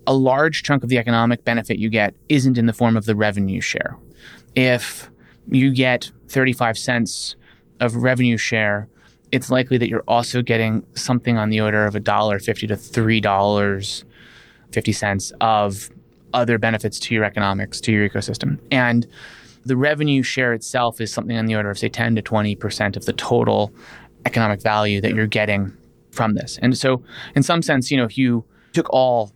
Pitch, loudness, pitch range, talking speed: 115 Hz, -19 LUFS, 105-125 Hz, 175 wpm